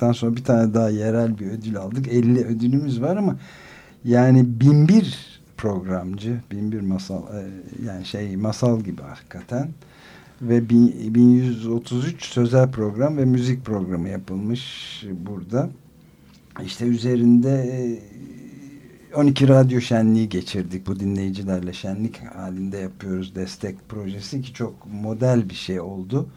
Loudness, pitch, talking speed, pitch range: -21 LUFS, 115 Hz, 115 wpm, 100-125 Hz